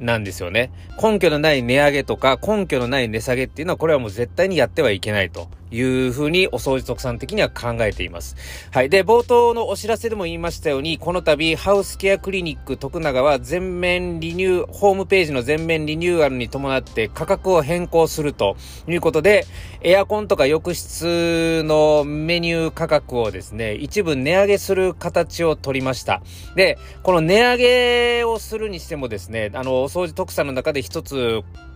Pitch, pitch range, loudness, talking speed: 155 Hz, 125-180 Hz, -19 LUFS, 380 characters per minute